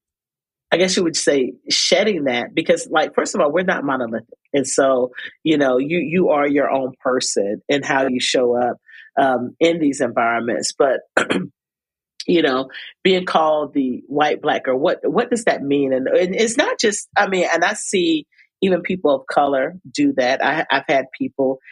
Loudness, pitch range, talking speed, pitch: -18 LUFS, 130-175 Hz, 190 wpm, 140 Hz